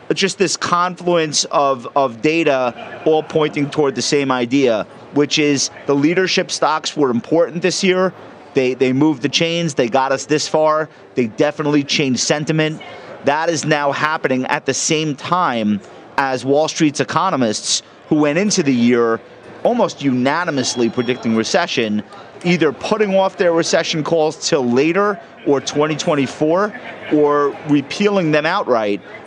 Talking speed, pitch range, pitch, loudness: 145 wpm, 135-165 Hz, 150 Hz, -17 LUFS